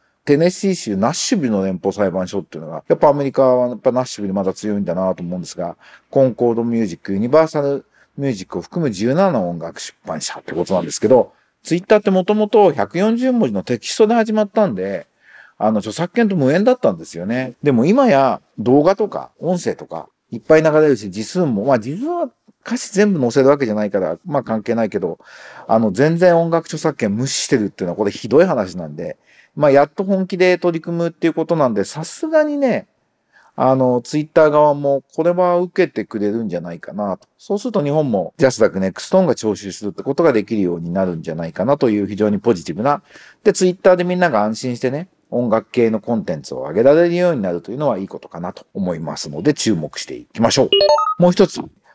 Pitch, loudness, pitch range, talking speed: 140 Hz, -17 LUFS, 110-180 Hz, 455 characters per minute